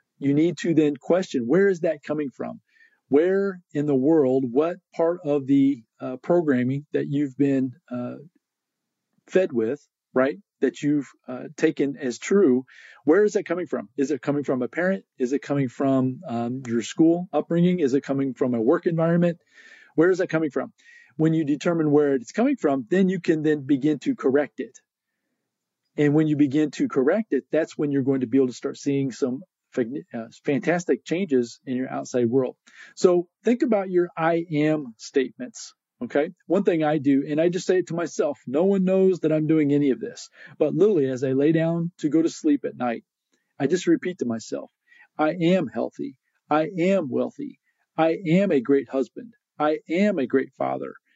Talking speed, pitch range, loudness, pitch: 190 wpm, 140-180 Hz, -23 LUFS, 155 Hz